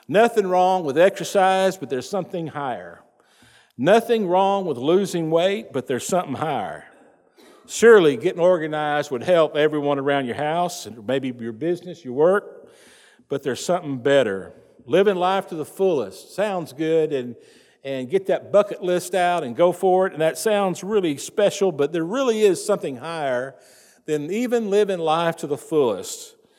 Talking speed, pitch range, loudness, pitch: 165 wpm, 150-195 Hz, -21 LUFS, 175 Hz